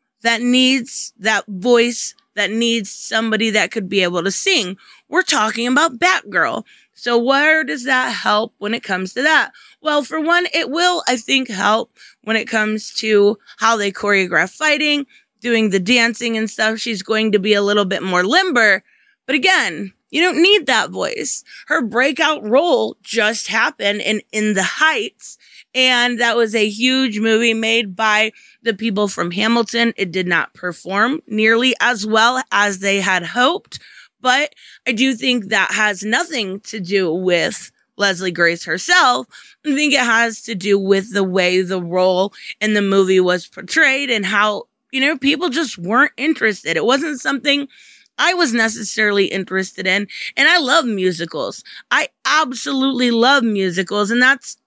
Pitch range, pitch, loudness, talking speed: 205-265 Hz, 225 Hz, -16 LUFS, 165 wpm